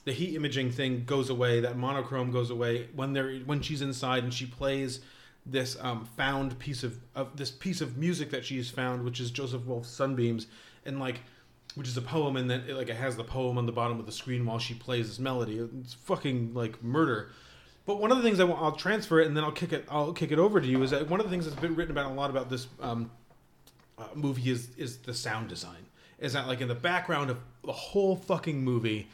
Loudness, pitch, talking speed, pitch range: -31 LUFS, 130 Hz, 245 wpm, 125-150 Hz